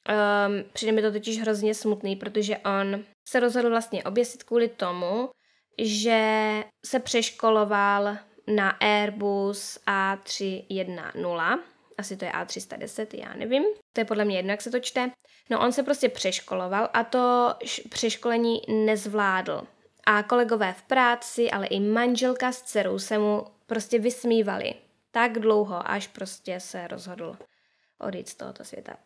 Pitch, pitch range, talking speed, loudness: 215 Hz, 200-240 Hz, 140 wpm, -26 LUFS